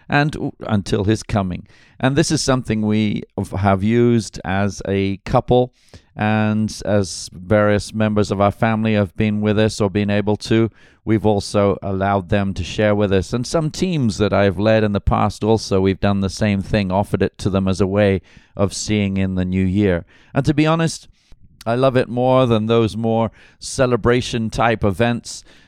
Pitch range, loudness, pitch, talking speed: 100-115 Hz, -18 LUFS, 105 Hz, 185 wpm